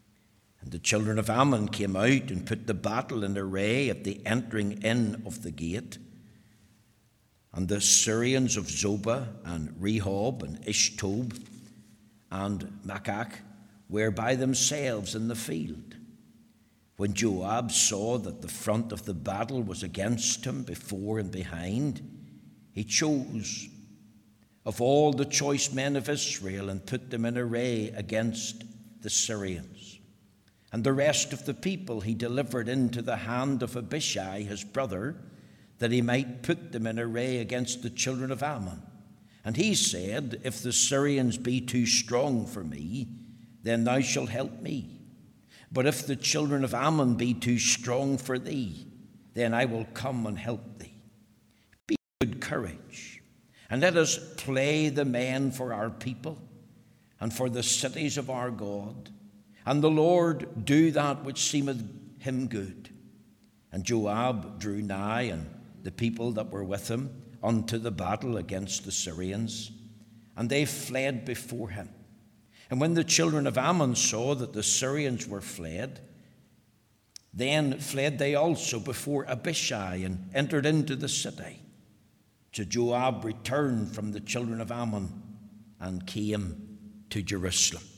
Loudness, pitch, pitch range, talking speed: -29 LUFS, 115 Hz, 105-130 Hz, 145 wpm